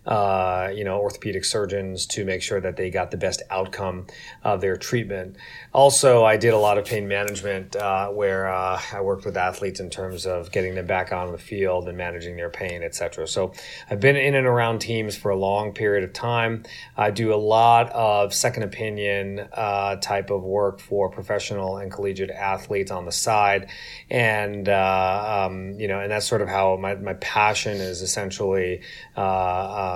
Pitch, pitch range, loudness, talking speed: 100 Hz, 95-105 Hz, -23 LUFS, 190 wpm